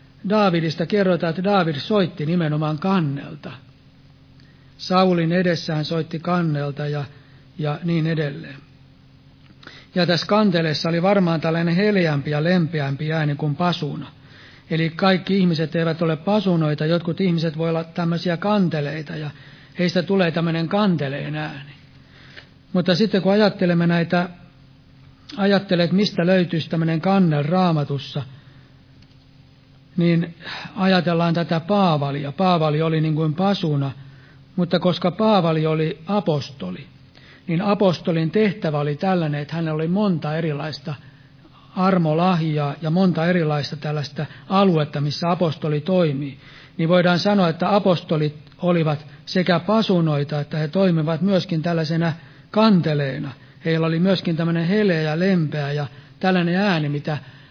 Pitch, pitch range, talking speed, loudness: 165 Hz, 145-180 Hz, 120 wpm, -20 LUFS